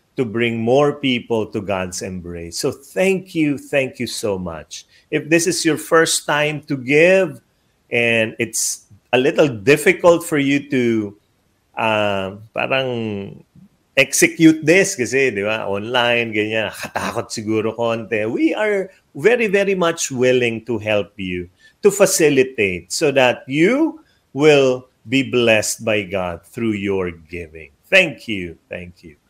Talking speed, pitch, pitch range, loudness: 135 wpm, 125 Hz, 105-150 Hz, -17 LUFS